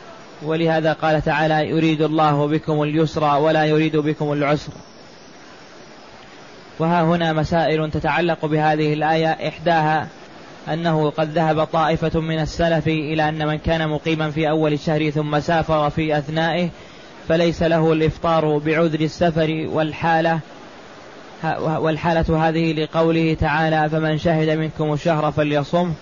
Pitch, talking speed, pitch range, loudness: 155 Hz, 120 wpm, 155-160 Hz, -19 LUFS